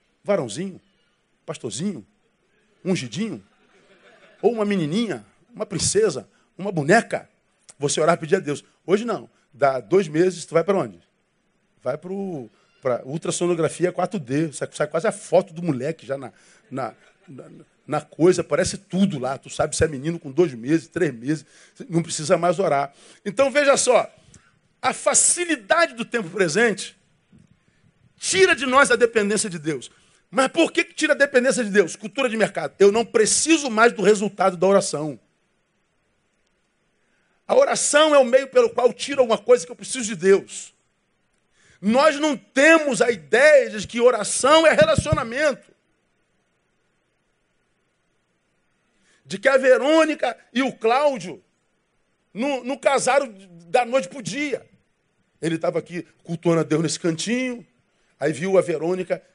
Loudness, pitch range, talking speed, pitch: -20 LUFS, 170-255 Hz, 145 wpm, 200 Hz